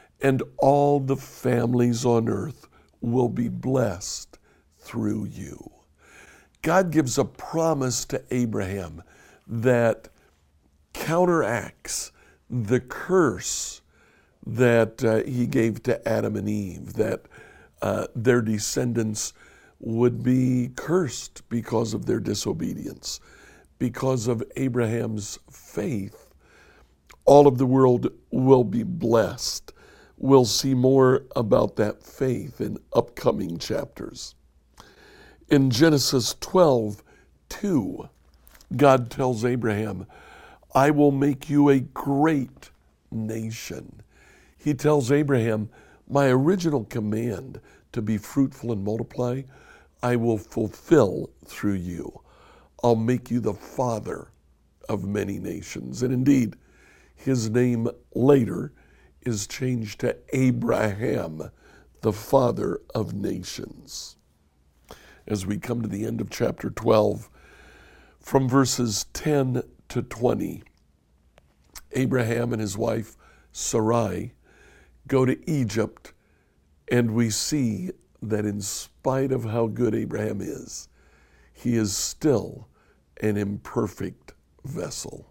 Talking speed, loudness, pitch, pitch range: 105 wpm, -24 LUFS, 120 Hz, 105-130 Hz